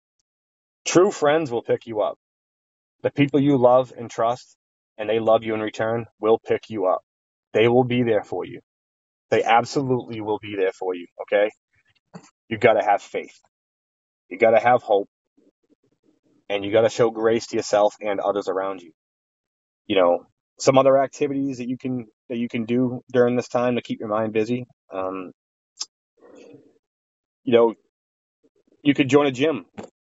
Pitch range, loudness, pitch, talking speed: 100-125 Hz, -22 LUFS, 115 Hz, 170 wpm